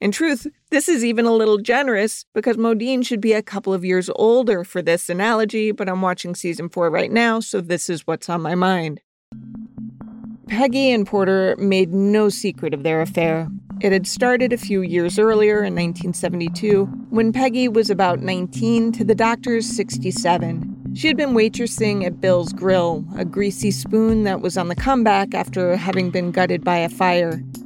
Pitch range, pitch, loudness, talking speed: 180-225 Hz, 200 Hz, -19 LUFS, 180 wpm